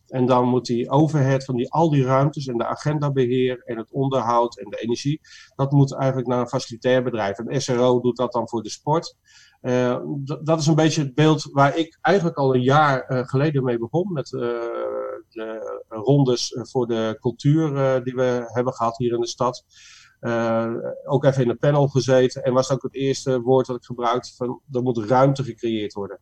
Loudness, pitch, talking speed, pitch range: -21 LUFS, 130 Hz, 210 wpm, 120-140 Hz